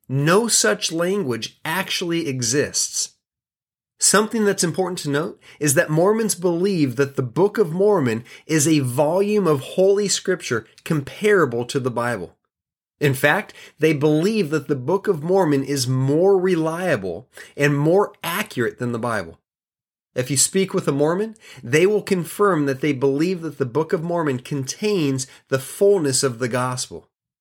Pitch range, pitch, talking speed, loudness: 140-190 Hz, 155 Hz, 155 wpm, -20 LUFS